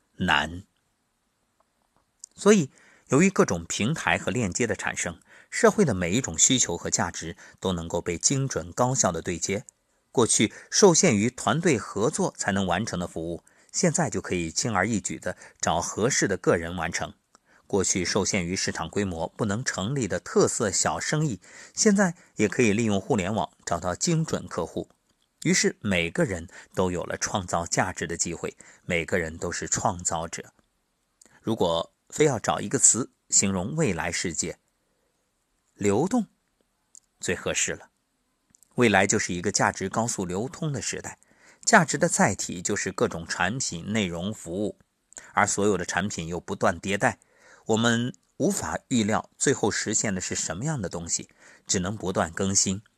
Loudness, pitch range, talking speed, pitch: -25 LUFS, 90-135 Hz, 240 characters per minute, 100 Hz